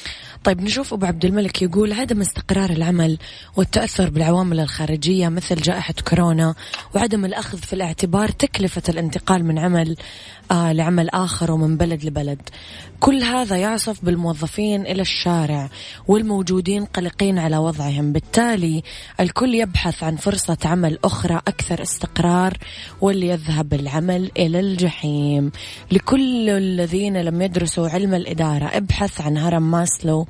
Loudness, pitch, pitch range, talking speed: -20 LUFS, 175 Hz, 160-195 Hz, 120 wpm